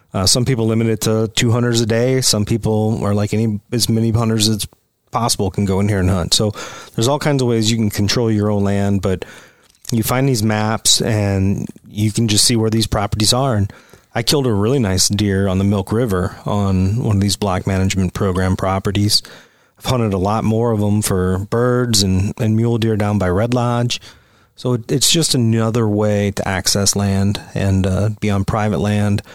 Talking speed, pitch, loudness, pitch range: 210 wpm, 105 Hz, -16 LUFS, 100-115 Hz